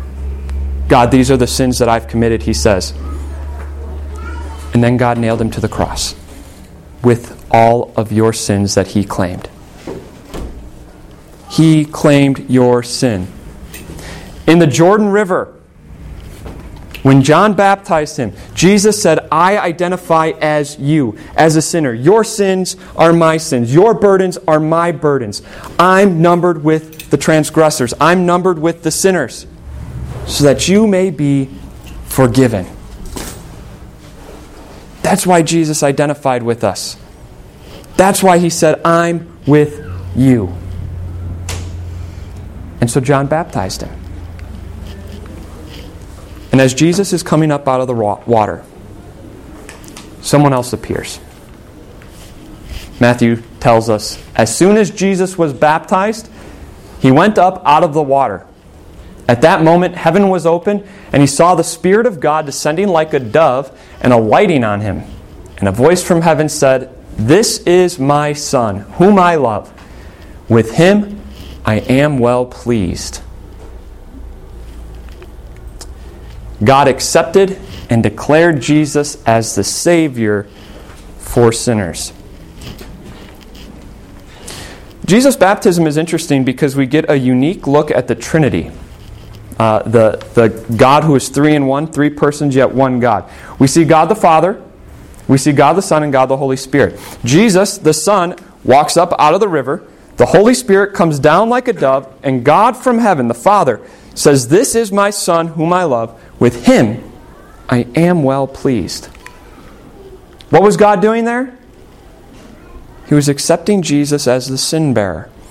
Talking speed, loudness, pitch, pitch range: 135 wpm, -12 LUFS, 135 Hz, 100-165 Hz